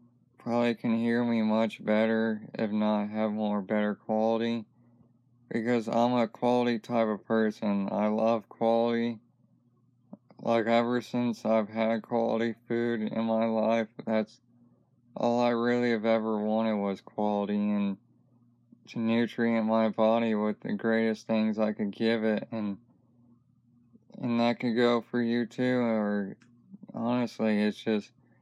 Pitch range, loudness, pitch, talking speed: 110-120 Hz, -29 LUFS, 115 Hz, 140 wpm